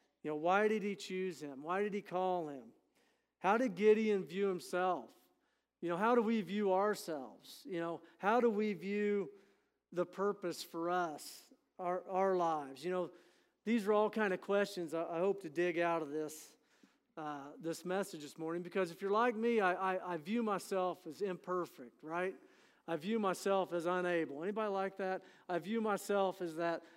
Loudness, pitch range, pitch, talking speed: -37 LUFS, 170-205 Hz, 185 Hz, 185 wpm